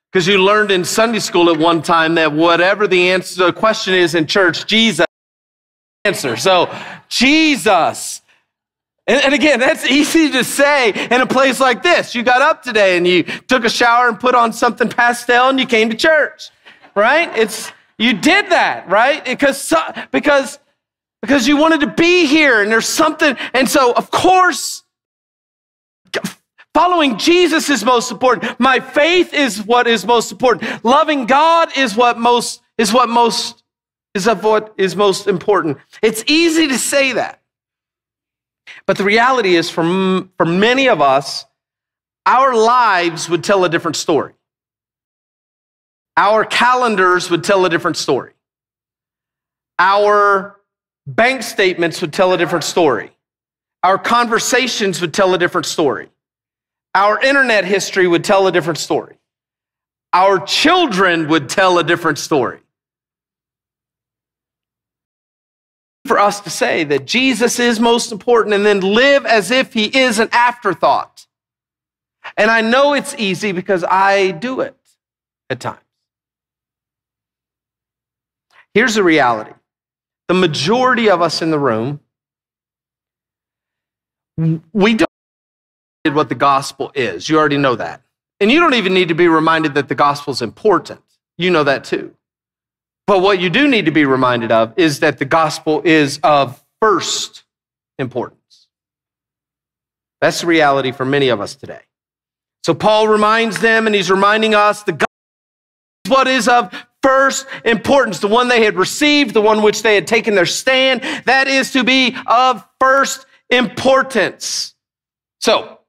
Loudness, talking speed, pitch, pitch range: -13 LUFS, 150 wpm, 220 Hz, 180-260 Hz